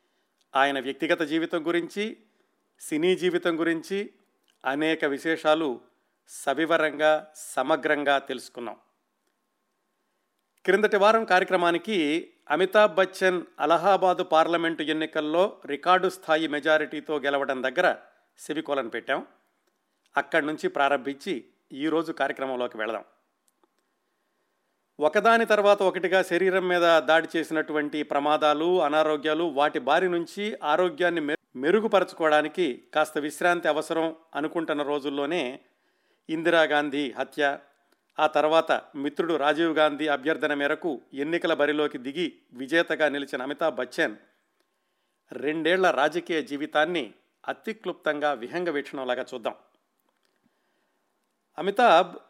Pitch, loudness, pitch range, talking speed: 160 Hz, -25 LUFS, 150-175 Hz, 90 wpm